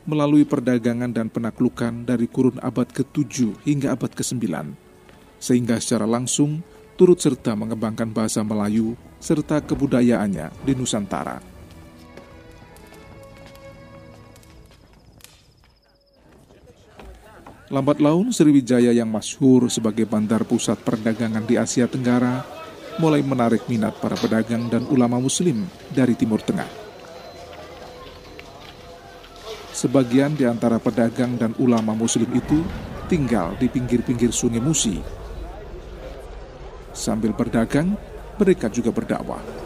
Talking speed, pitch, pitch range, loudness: 95 wpm, 120 Hz, 110-135 Hz, -21 LUFS